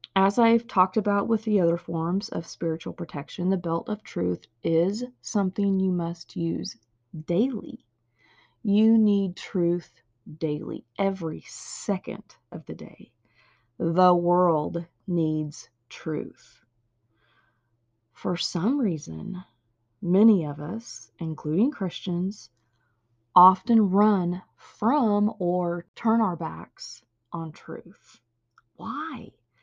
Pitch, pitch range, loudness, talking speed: 175 Hz, 150-200 Hz, -25 LUFS, 105 wpm